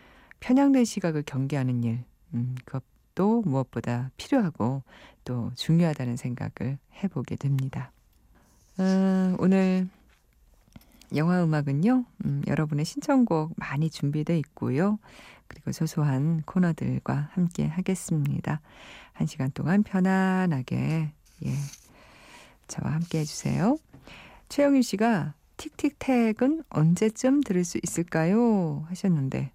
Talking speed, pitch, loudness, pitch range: 250 characters per minute, 160 Hz, -27 LUFS, 135-195 Hz